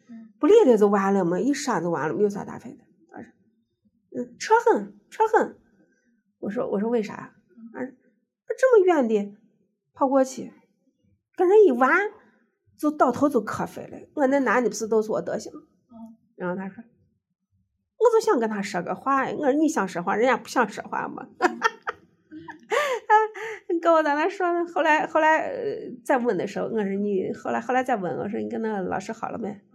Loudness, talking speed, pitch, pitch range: -23 LUFS, 255 characters per minute, 250 Hz, 215-325 Hz